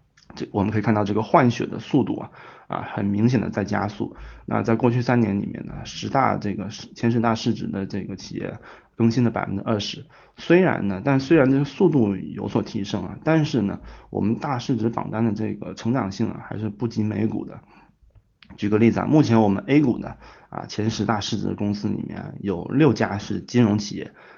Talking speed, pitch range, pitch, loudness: 305 characters per minute, 105-120 Hz, 110 Hz, -23 LUFS